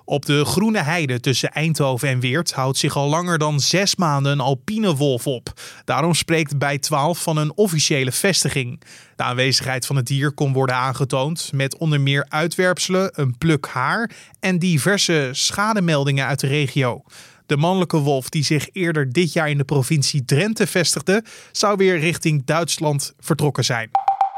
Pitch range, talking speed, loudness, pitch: 140-175 Hz, 165 wpm, -19 LUFS, 150 Hz